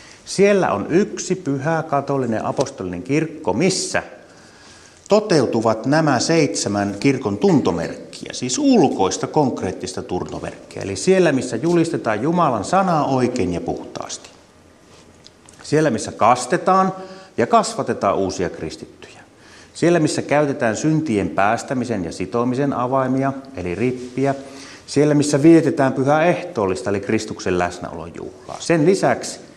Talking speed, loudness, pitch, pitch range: 110 wpm, -19 LUFS, 135 Hz, 110-160 Hz